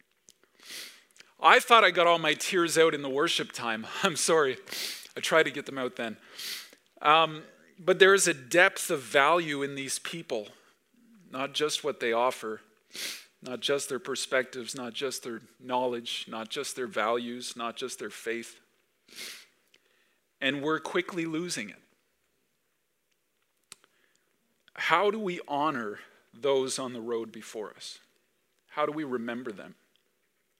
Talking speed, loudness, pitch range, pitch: 145 wpm, -28 LUFS, 120-165 Hz, 140 Hz